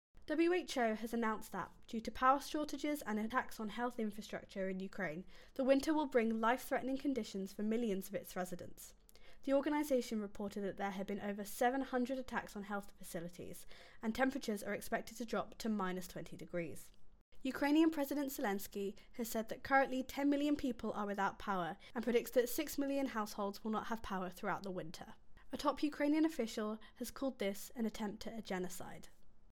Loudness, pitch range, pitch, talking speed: -39 LUFS, 200-265 Hz, 225 Hz, 175 wpm